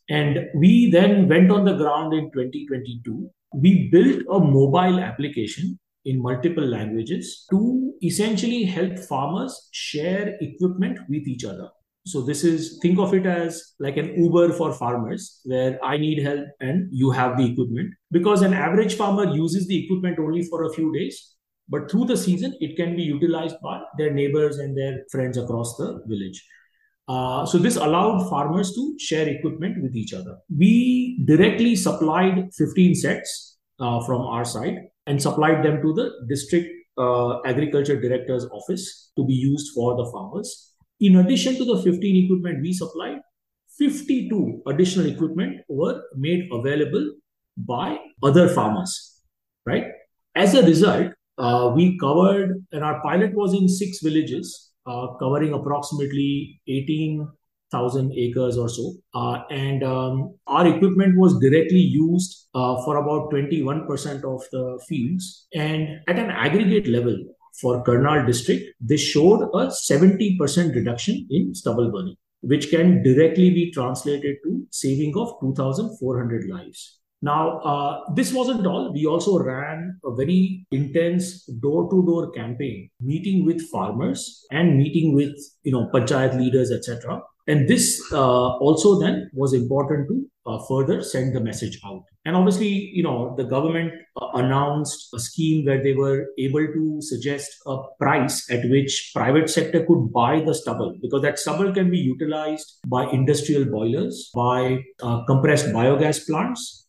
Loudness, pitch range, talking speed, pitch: -21 LUFS, 135-180 Hz, 150 wpm, 150 Hz